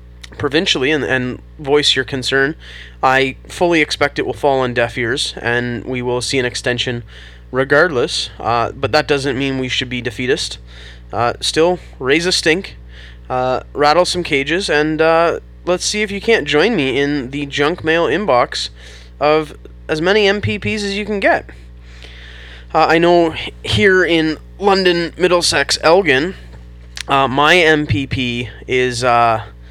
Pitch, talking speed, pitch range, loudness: 130 Hz, 150 wpm, 100-160 Hz, -15 LUFS